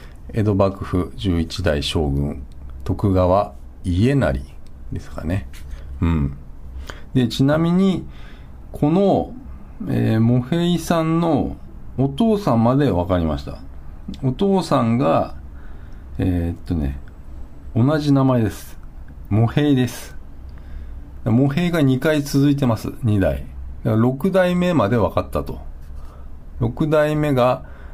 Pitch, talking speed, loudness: 90 Hz, 185 characters per minute, -19 LUFS